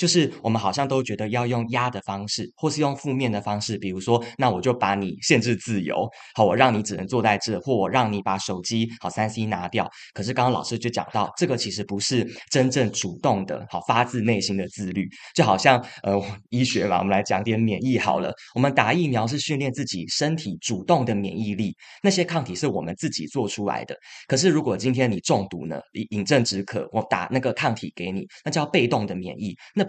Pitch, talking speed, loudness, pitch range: 115 Hz, 325 characters per minute, -24 LUFS, 100-130 Hz